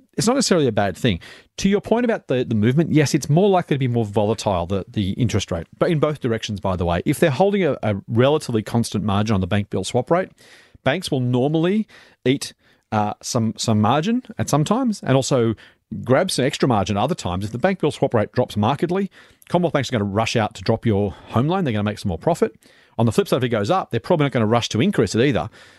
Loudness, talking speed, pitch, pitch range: -20 LUFS, 255 wpm, 120 Hz, 105-160 Hz